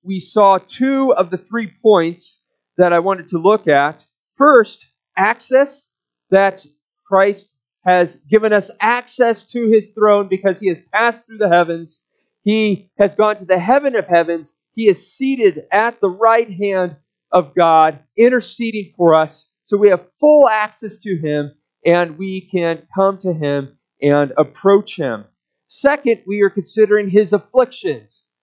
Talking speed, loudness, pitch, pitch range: 155 wpm, -15 LUFS, 195 Hz, 170-220 Hz